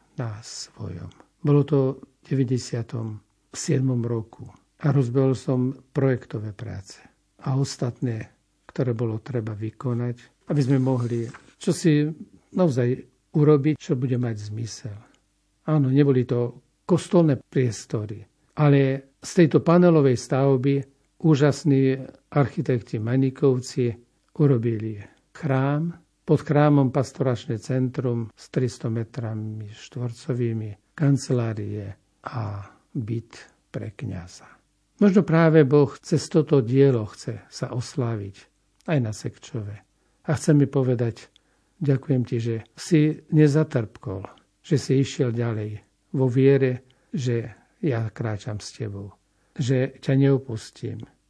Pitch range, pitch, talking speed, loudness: 115-145 Hz, 130 Hz, 110 wpm, -23 LUFS